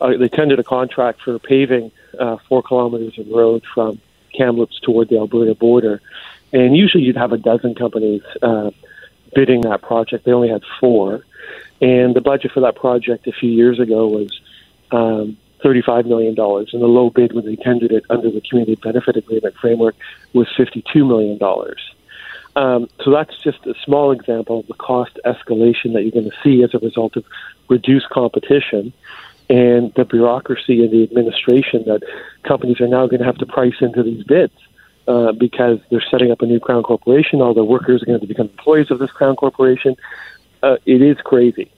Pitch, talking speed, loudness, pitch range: 120 Hz, 190 wpm, -15 LUFS, 115-130 Hz